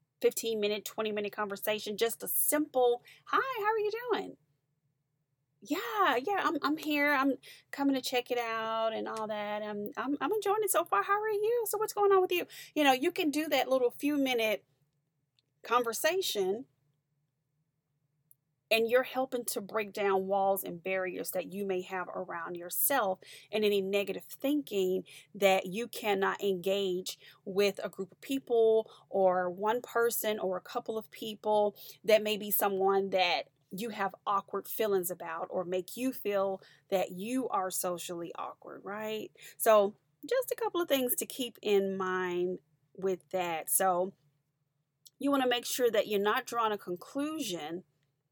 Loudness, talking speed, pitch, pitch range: -31 LUFS, 165 wpm, 210 Hz, 185-260 Hz